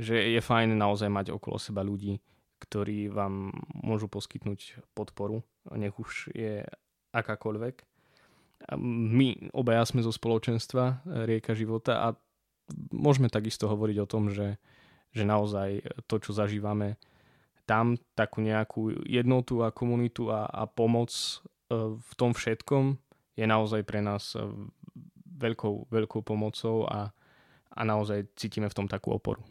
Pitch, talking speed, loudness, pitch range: 110 Hz, 130 wpm, -31 LUFS, 105-115 Hz